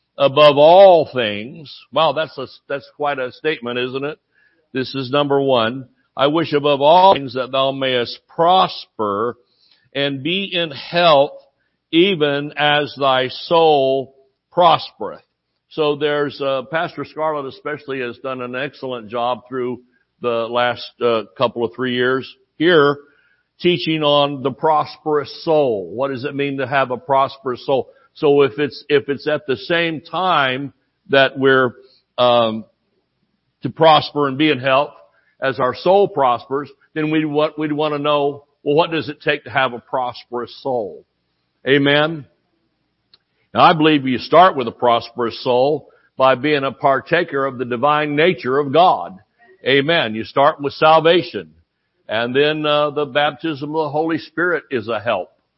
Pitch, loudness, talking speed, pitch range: 140 Hz, -17 LUFS, 155 wpm, 130-150 Hz